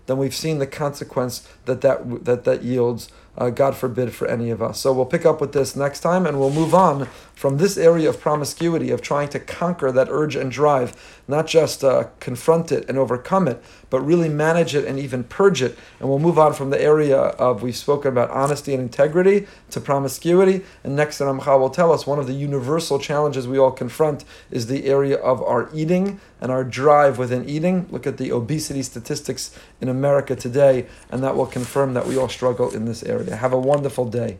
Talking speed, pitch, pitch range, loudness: 215 wpm, 140 Hz, 130-150 Hz, -20 LUFS